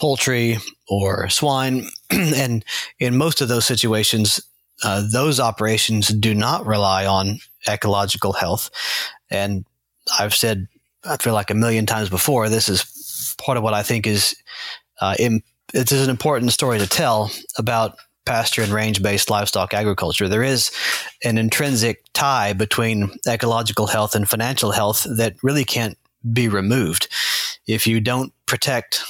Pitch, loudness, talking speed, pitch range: 110 Hz, -19 LUFS, 145 wpm, 105-120 Hz